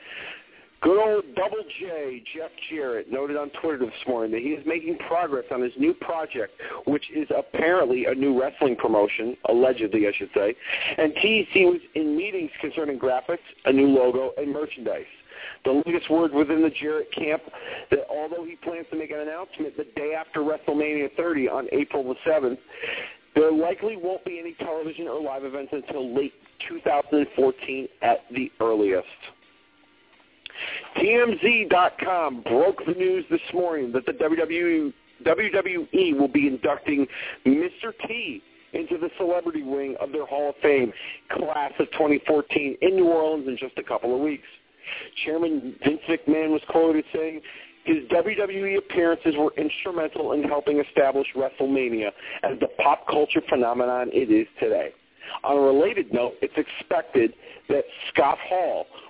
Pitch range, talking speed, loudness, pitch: 140-185 Hz, 150 wpm, -24 LUFS, 155 Hz